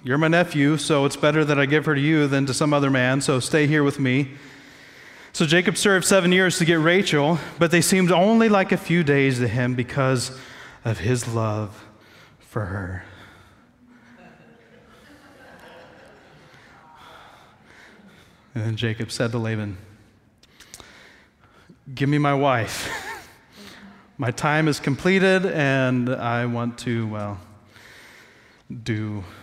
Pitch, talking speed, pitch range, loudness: 135 Hz, 135 wpm, 115-155 Hz, -21 LUFS